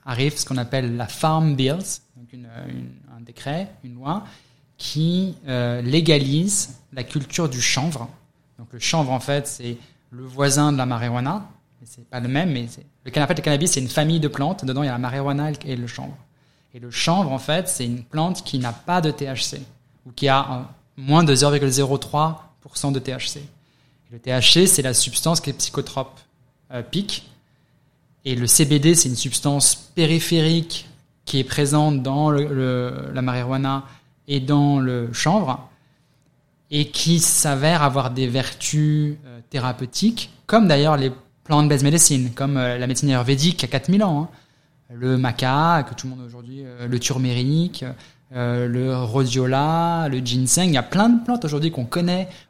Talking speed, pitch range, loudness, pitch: 170 wpm, 130-150 Hz, -20 LUFS, 140 Hz